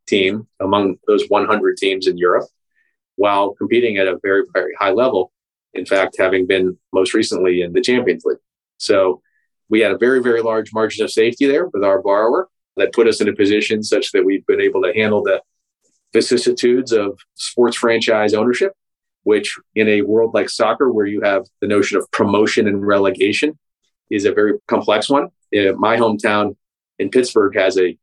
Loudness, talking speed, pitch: -16 LUFS, 180 wpm, 115 Hz